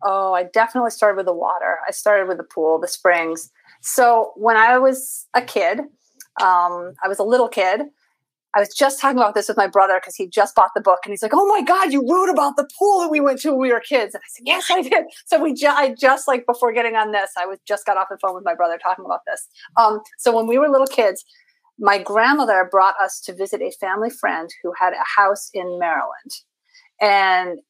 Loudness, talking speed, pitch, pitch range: -18 LUFS, 245 wpm, 220 Hz, 190-275 Hz